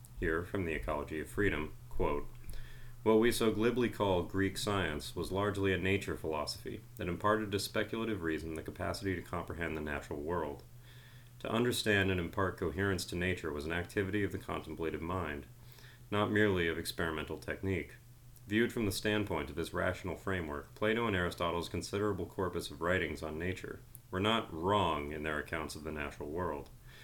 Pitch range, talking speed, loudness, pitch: 80-110 Hz, 170 wpm, -35 LUFS, 95 Hz